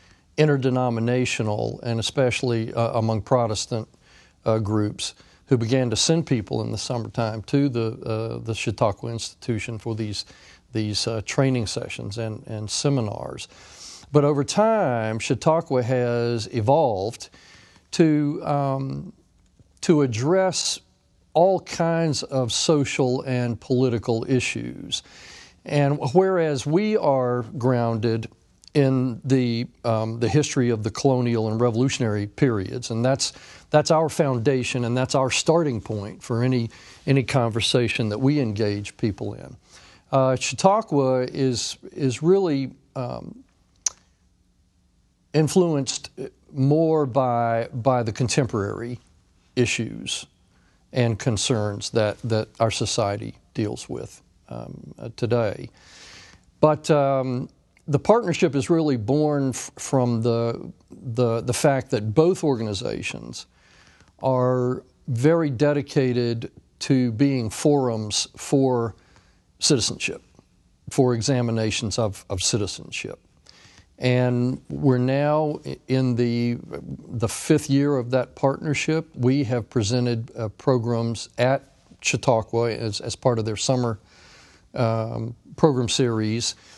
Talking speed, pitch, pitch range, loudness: 115 wpm, 125 Hz, 115-140 Hz, -23 LUFS